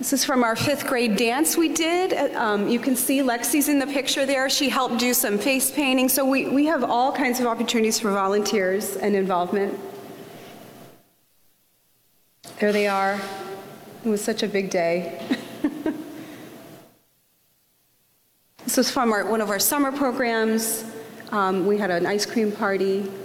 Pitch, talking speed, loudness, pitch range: 225 Hz, 155 wpm, -22 LUFS, 200-270 Hz